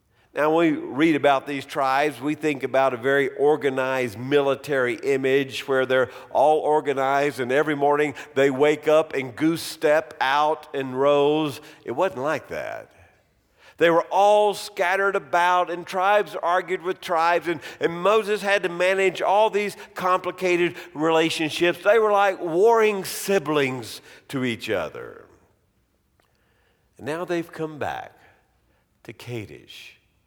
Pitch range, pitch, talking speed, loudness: 140-185 Hz, 155 Hz, 140 wpm, -22 LUFS